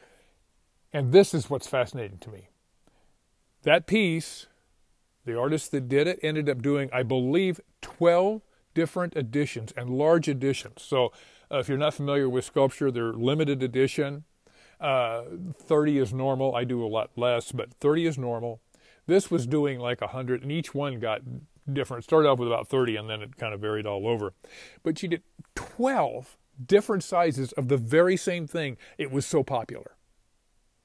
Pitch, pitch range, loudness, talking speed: 140 Hz, 120-160 Hz, -27 LUFS, 170 wpm